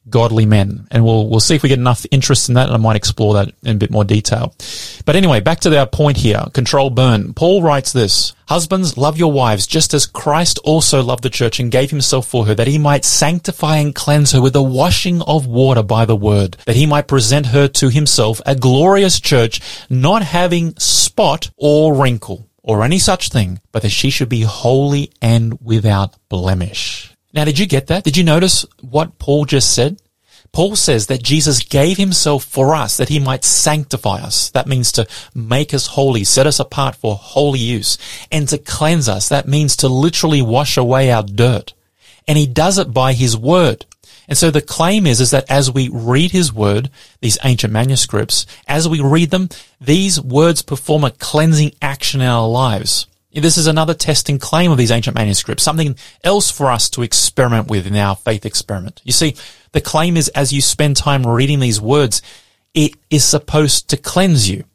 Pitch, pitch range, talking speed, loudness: 135 Hz, 115-150 Hz, 200 wpm, -13 LUFS